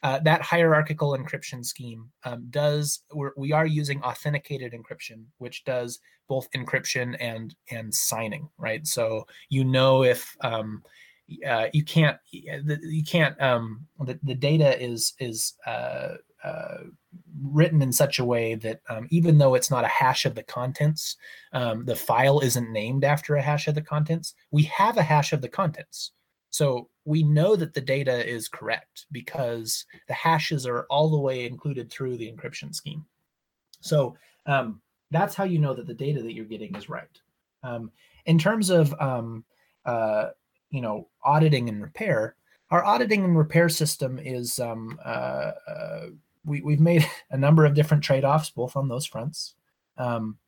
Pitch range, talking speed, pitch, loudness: 120-155 Hz, 165 wpm, 140 Hz, -25 LUFS